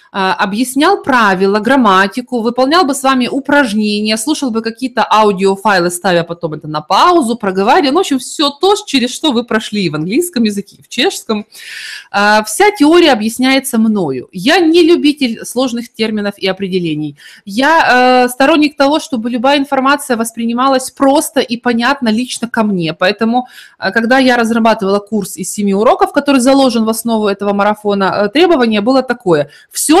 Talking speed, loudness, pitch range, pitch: 150 wpm, -12 LUFS, 205-275 Hz, 240 Hz